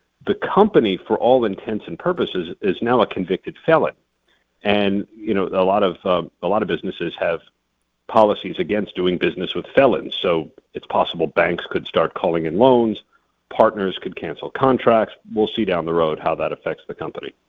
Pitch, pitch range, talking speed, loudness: 100 Hz, 85-110 Hz, 180 wpm, -20 LUFS